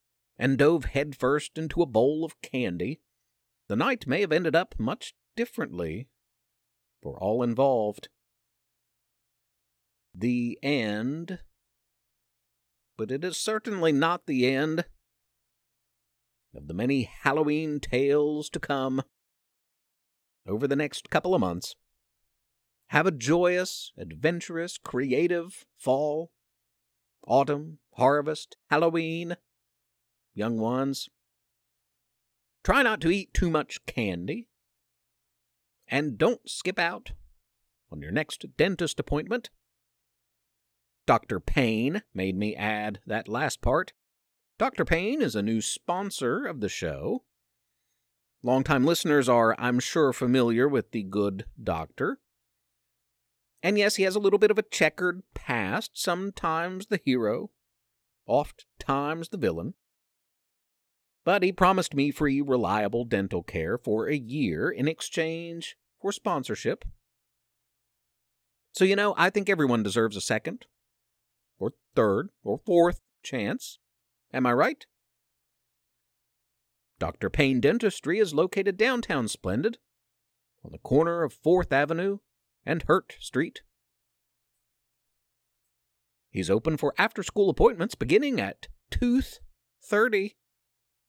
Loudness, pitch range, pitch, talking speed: -27 LUFS, 105-165 Hz, 125 Hz, 115 wpm